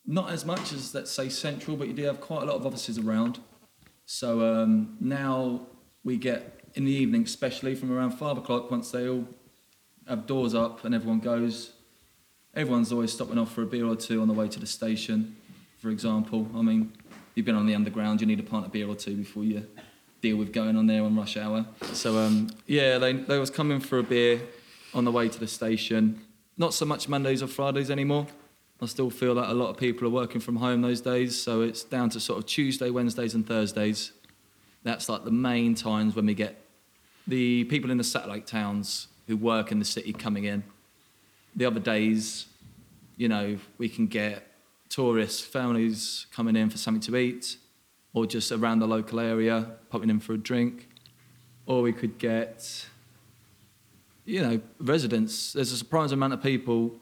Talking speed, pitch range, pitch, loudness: 200 wpm, 110-130 Hz, 115 Hz, -28 LUFS